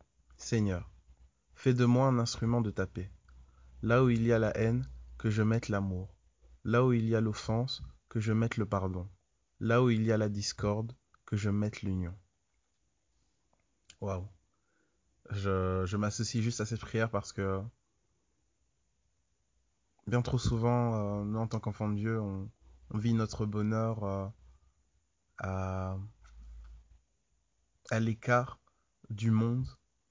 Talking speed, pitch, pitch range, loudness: 145 wpm, 100 Hz, 85-115 Hz, -32 LUFS